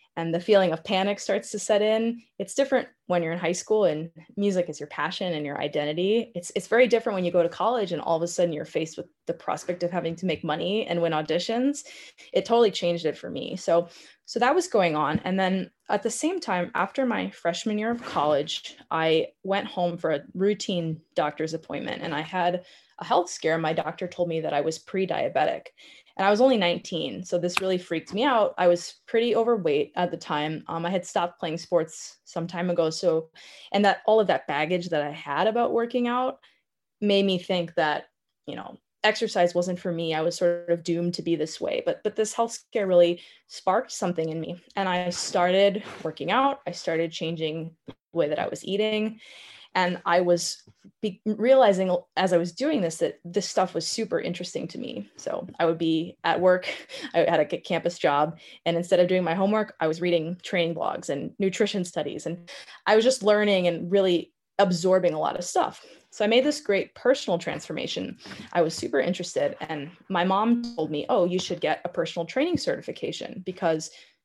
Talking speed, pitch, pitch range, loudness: 210 wpm, 180 Hz, 170-215 Hz, -26 LUFS